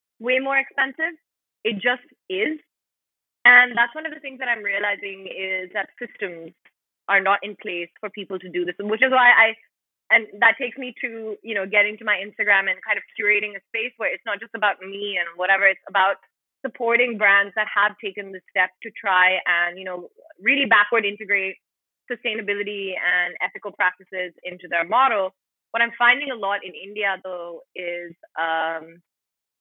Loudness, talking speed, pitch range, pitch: -21 LUFS, 185 wpm, 185-235 Hz, 205 Hz